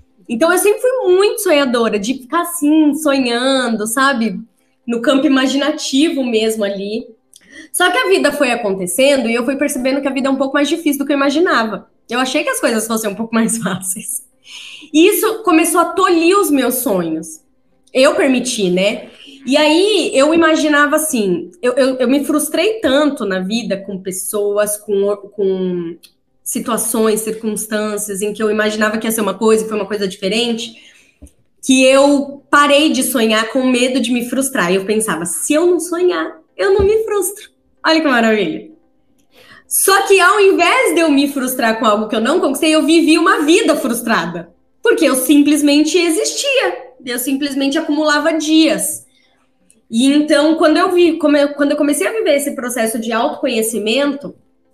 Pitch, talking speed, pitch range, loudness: 270 Hz, 170 wpm, 220-310 Hz, -14 LUFS